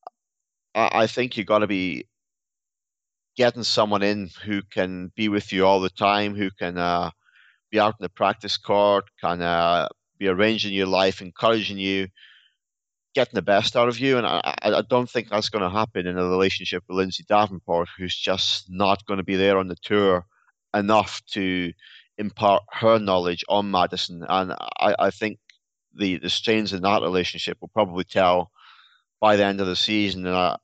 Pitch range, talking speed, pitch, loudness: 90-105 Hz, 180 wpm, 100 Hz, -23 LUFS